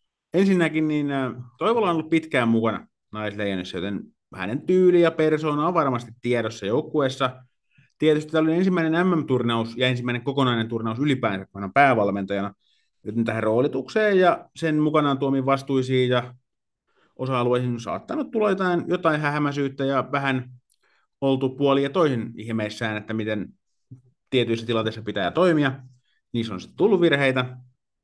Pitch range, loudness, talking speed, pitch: 115-155 Hz, -23 LUFS, 130 wpm, 130 Hz